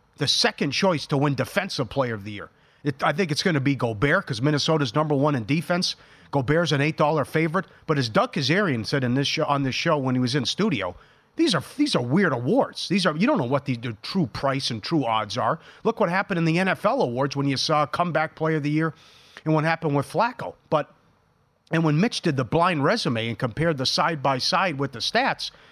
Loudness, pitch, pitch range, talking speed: -23 LUFS, 150 Hz, 140-170 Hz, 235 wpm